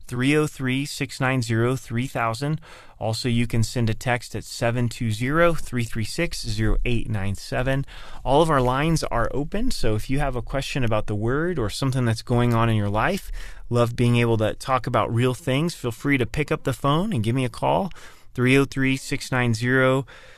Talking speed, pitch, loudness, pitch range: 155 wpm, 125 Hz, -23 LUFS, 115-135 Hz